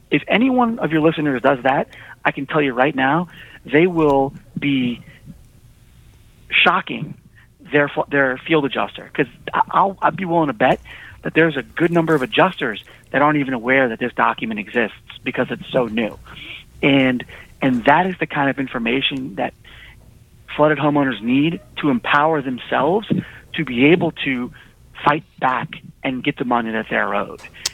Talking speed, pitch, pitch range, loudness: 165 wpm, 140 Hz, 130-160 Hz, -19 LUFS